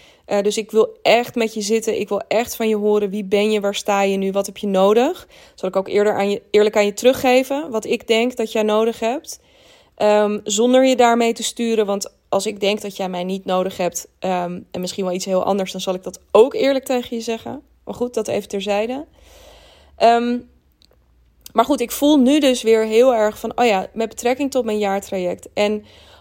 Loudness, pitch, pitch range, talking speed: -19 LUFS, 215 Hz, 200-240 Hz, 225 wpm